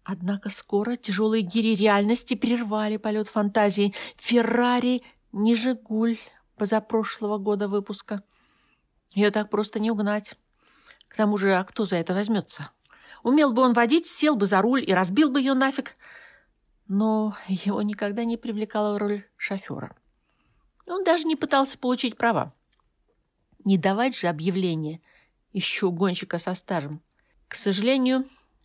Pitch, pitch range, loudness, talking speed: 215 Hz, 200-245 Hz, -24 LUFS, 130 wpm